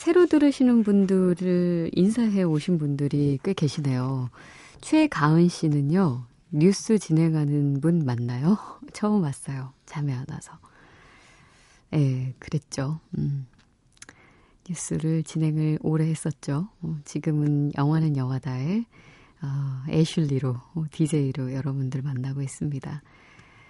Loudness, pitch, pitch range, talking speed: -25 LUFS, 155 Hz, 140-175 Hz, 235 characters per minute